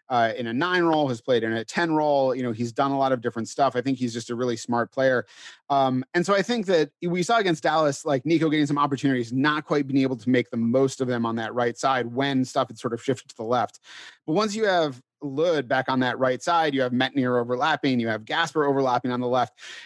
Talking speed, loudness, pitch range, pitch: 265 wpm, -24 LUFS, 125-150 Hz, 135 Hz